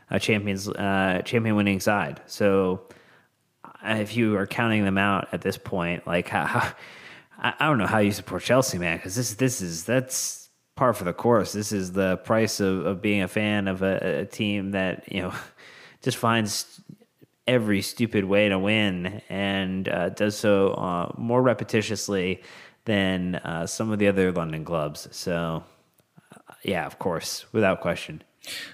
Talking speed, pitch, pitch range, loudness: 165 wpm, 100 Hz, 95-110 Hz, -25 LUFS